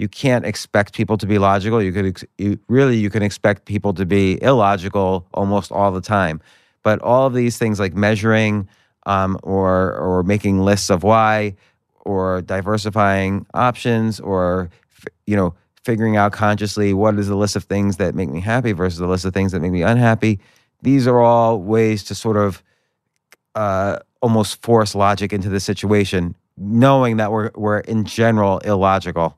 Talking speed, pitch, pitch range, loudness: 180 wpm, 100 Hz, 95-110 Hz, -17 LUFS